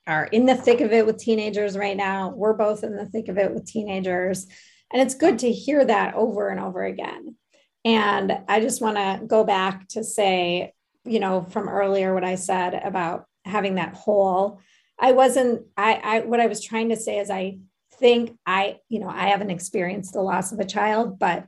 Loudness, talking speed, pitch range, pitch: -22 LUFS, 205 wpm, 190-225 Hz, 210 Hz